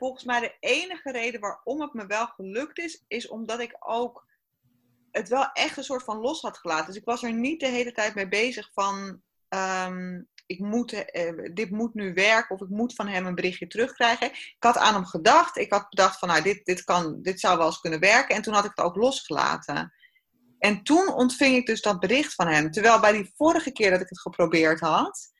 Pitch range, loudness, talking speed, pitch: 185-245 Hz, -25 LUFS, 225 wpm, 215 Hz